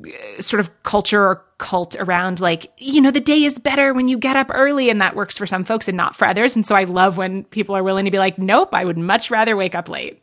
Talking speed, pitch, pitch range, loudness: 275 wpm, 205 Hz, 190-255 Hz, -17 LUFS